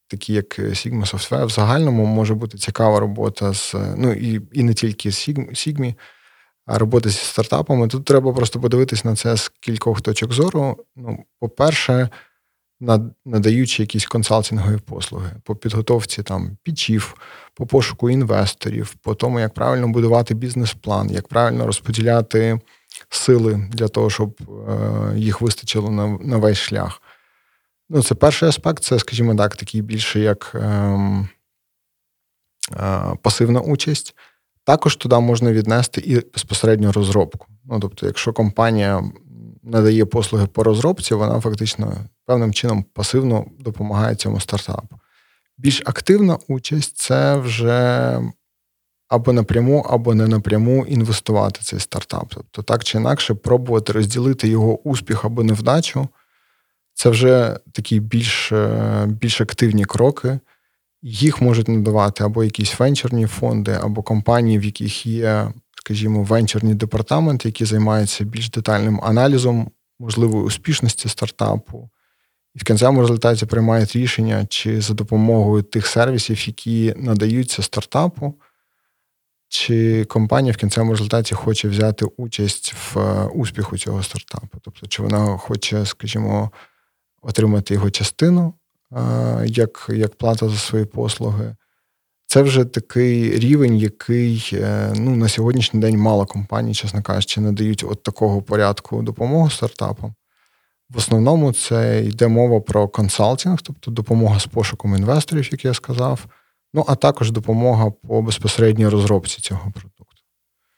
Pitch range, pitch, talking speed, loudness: 105-120 Hz, 110 Hz, 125 wpm, -18 LUFS